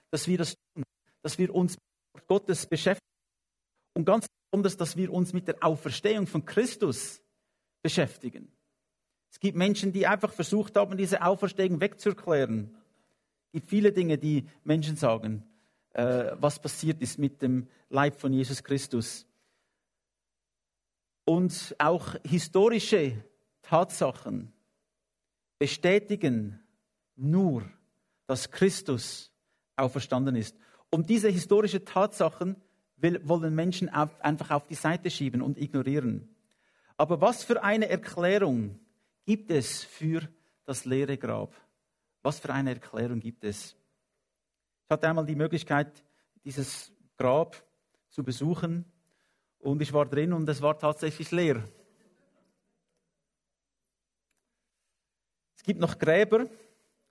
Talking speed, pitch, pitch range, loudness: 120 wpm, 160 Hz, 140-190 Hz, -29 LUFS